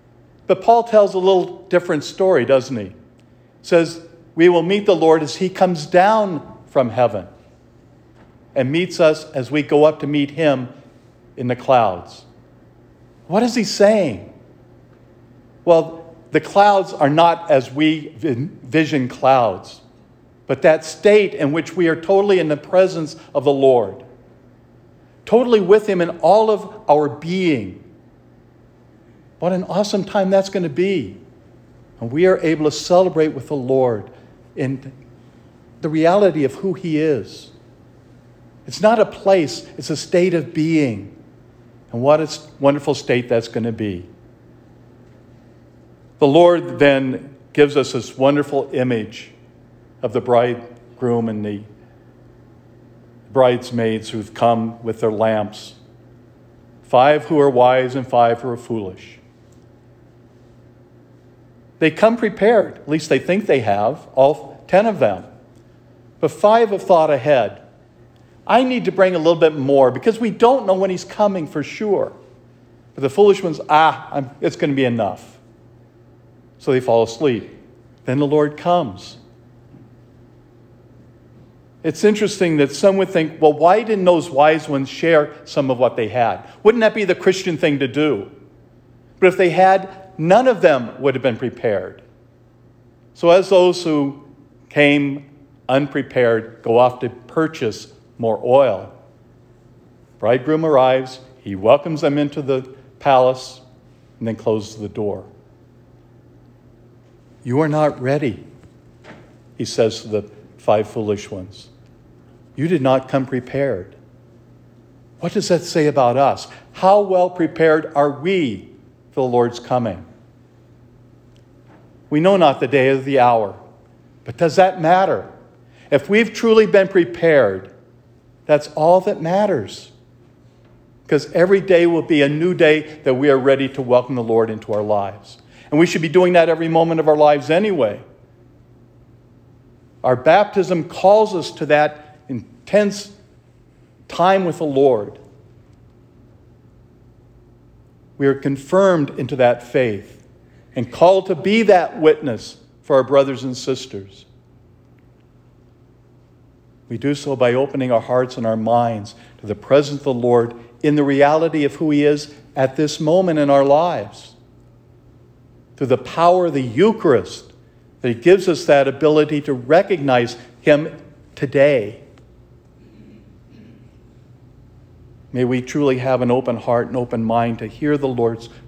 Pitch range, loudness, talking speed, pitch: 120-165 Hz, -17 LUFS, 145 wpm, 140 Hz